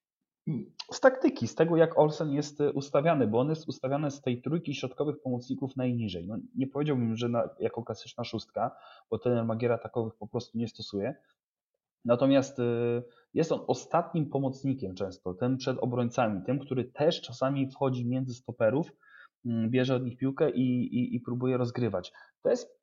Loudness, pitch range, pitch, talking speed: -30 LUFS, 120-140 Hz, 125 Hz, 160 wpm